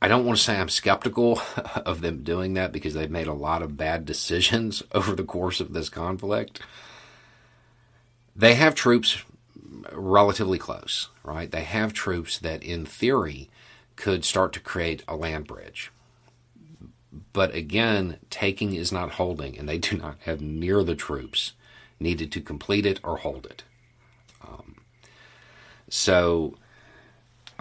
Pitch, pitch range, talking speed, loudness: 95 Hz, 80-110 Hz, 145 wpm, -25 LUFS